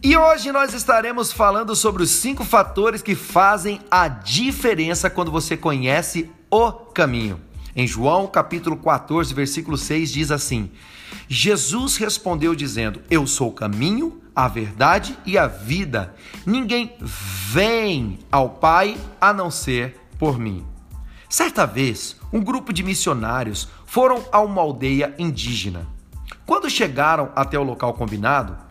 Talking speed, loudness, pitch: 135 wpm, -20 LUFS, 160 Hz